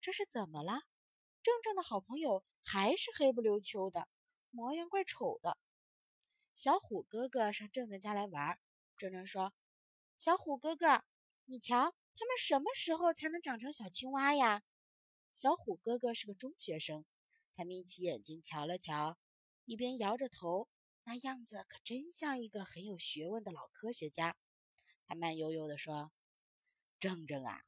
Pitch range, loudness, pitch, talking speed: 180-285 Hz, -39 LUFS, 230 Hz, 225 characters per minute